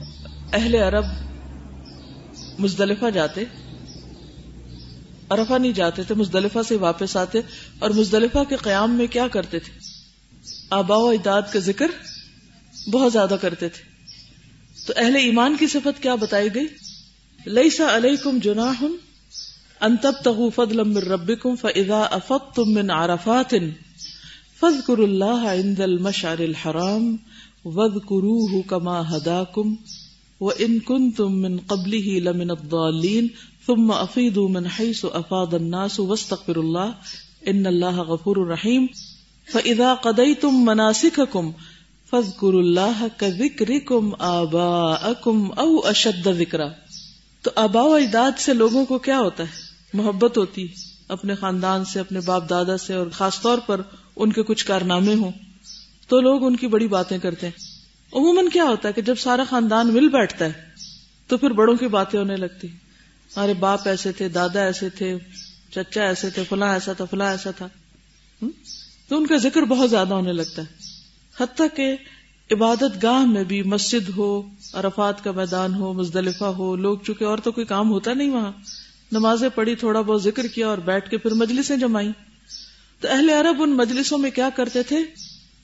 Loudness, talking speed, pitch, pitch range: -21 LUFS, 135 wpm, 205 Hz, 185-235 Hz